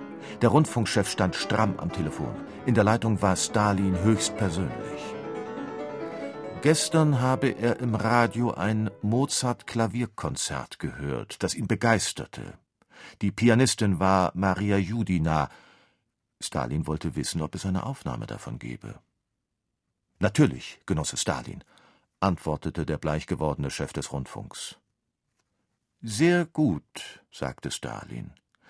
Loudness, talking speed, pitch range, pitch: -27 LUFS, 105 wpm, 90-120 Hz, 105 Hz